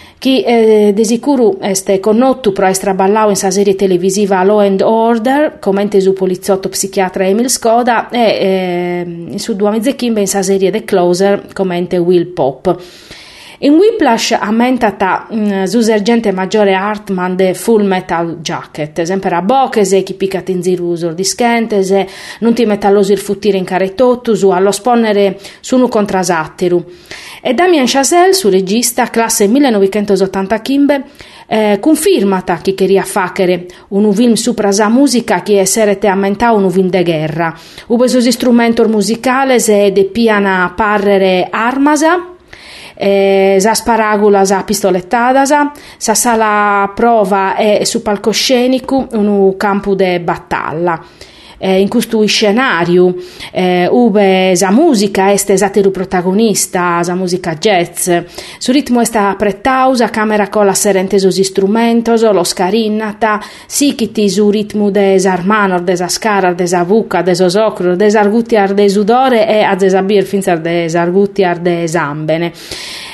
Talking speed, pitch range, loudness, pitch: 140 wpm, 190-225 Hz, -11 LUFS, 200 Hz